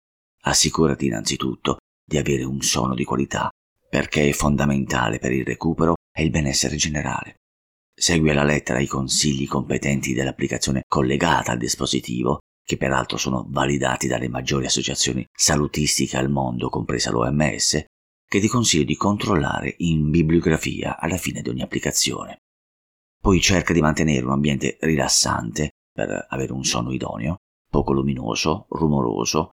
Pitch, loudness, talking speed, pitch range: 70 Hz, -21 LUFS, 135 wpm, 65-75 Hz